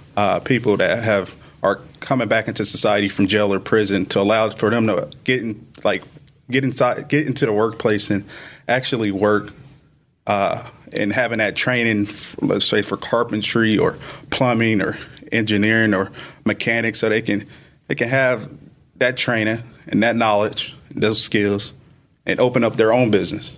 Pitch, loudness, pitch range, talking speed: 110 Hz, -19 LUFS, 105-130 Hz, 160 wpm